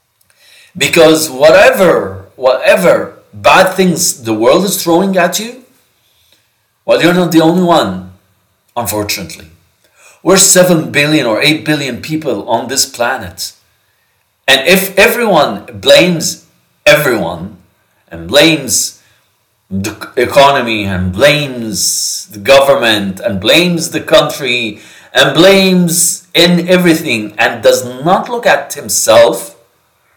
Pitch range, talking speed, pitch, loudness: 105-175 Hz, 110 wpm, 145 Hz, -9 LUFS